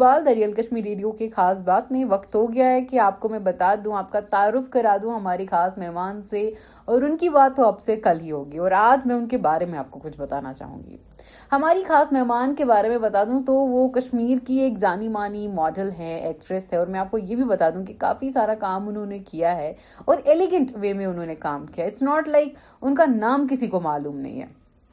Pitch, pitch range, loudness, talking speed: 210 Hz, 185-255 Hz, -22 LUFS, 250 wpm